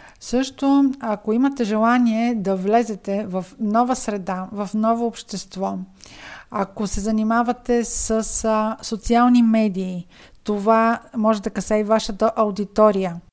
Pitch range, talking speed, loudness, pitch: 205-230 Hz, 115 wpm, -20 LUFS, 220 Hz